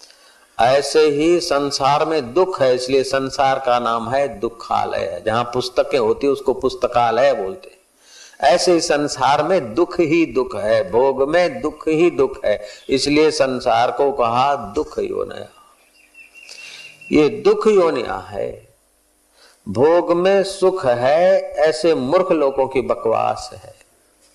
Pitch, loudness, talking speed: 165 Hz, -17 LUFS, 130 wpm